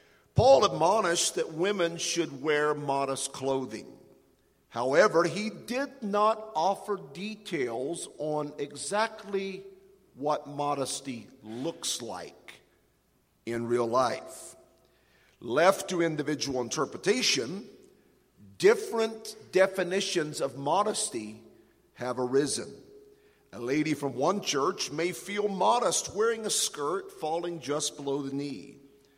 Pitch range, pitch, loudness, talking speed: 140-205 Hz, 160 Hz, -29 LUFS, 100 wpm